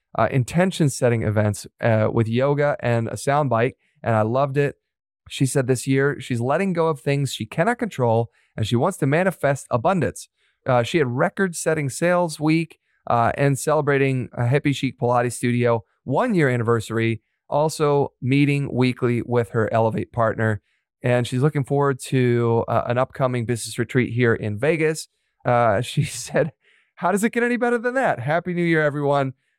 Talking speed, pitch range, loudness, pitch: 175 wpm, 120-150 Hz, -21 LUFS, 130 Hz